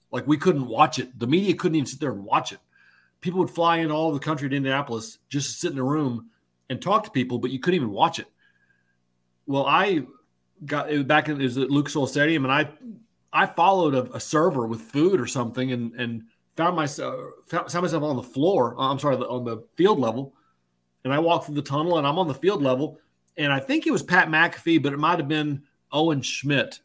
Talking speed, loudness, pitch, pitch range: 225 wpm, -24 LUFS, 140 Hz, 125-155 Hz